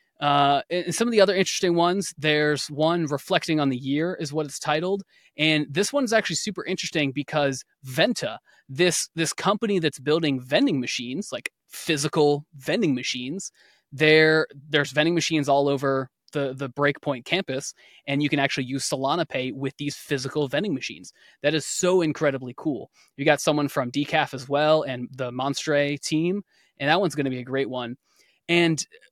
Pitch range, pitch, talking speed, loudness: 140-165 Hz, 150 Hz, 175 wpm, -24 LUFS